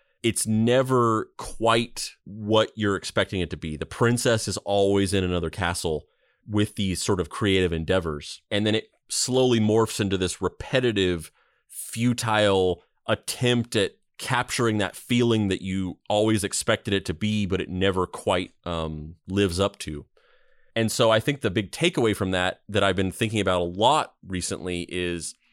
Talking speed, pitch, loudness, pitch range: 160 wpm, 100 Hz, -24 LUFS, 90-110 Hz